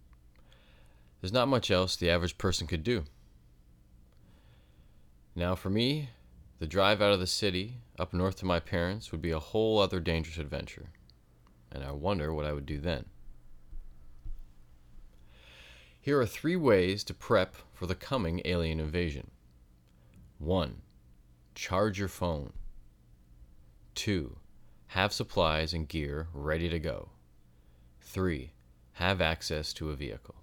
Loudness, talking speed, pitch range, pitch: -32 LUFS, 130 wpm, 60-90 Hz, 75 Hz